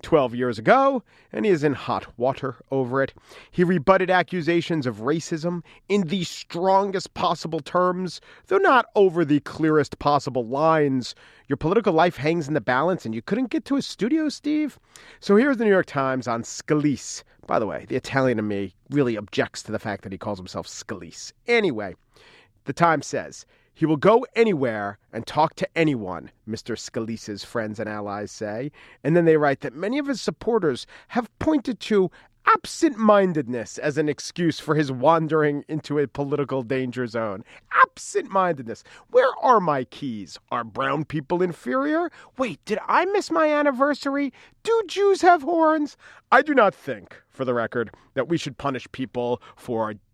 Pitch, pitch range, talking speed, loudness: 155 Hz, 125-200 Hz, 170 wpm, -23 LUFS